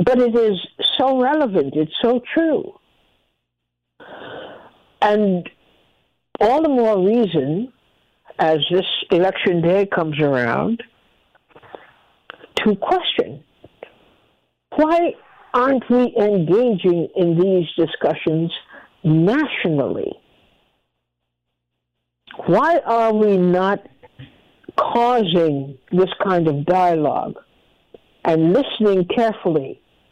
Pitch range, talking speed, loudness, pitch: 160-235 Hz, 80 wpm, -18 LUFS, 185 Hz